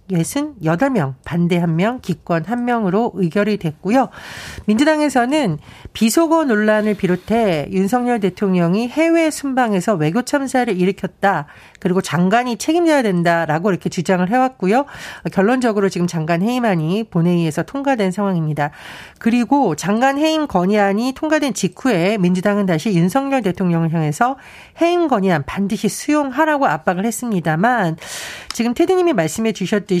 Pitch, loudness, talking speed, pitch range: 205 Hz, -17 LUFS, 340 characters per minute, 175-250 Hz